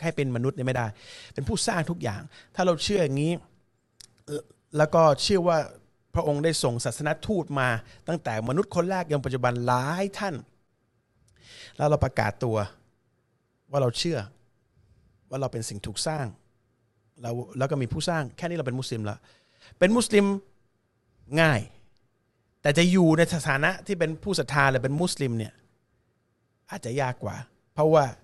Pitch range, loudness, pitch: 120-160 Hz, -26 LUFS, 130 Hz